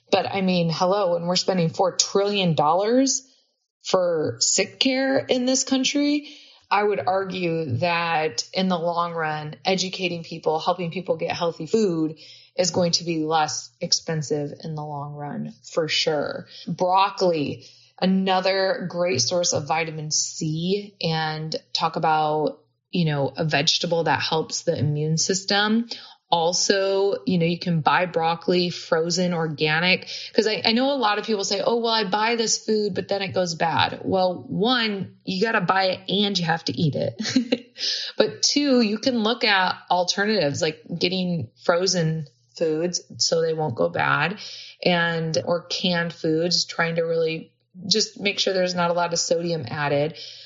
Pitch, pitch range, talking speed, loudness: 175 Hz, 160-200 Hz, 165 wpm, -22 LUFS